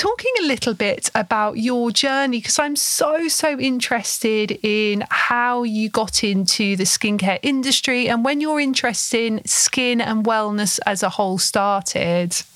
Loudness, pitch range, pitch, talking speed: -18 LUFS, 210-265 Hz, 230 Hz, 155 wpm